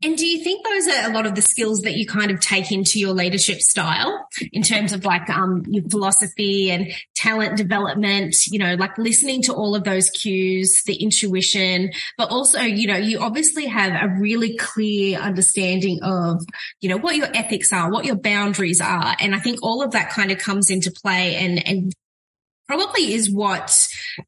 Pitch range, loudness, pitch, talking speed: 190-220 Hz, -18 LUFS, 200 Hz, 195 wpm